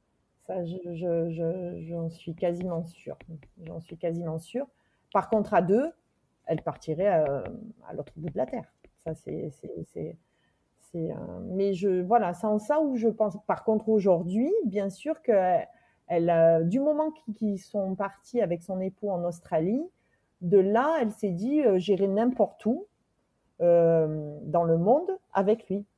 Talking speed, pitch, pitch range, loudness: 170 wpm, 195 Hz, 170-220 Hz, -27 LUFS